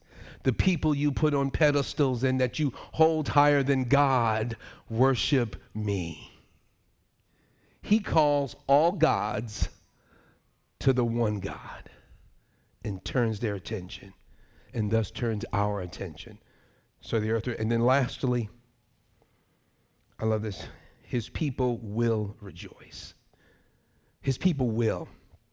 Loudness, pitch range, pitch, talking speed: -28 LUFS, 105-135 Hz, 115 Hz, 115 wpm